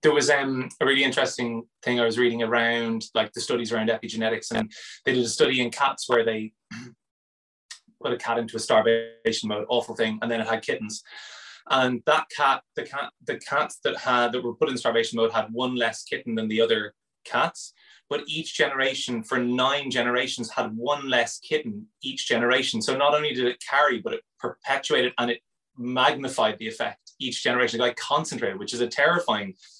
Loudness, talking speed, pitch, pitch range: -25 LUFS, 195 wpm, 120 Hz, 115-135 Hz